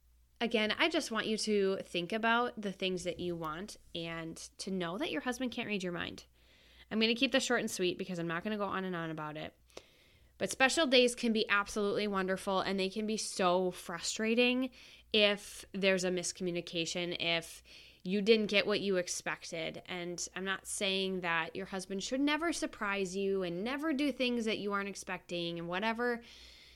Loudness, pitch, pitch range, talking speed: -34 LUFS, 195 Hz, 175-225 Hz, 195 wpm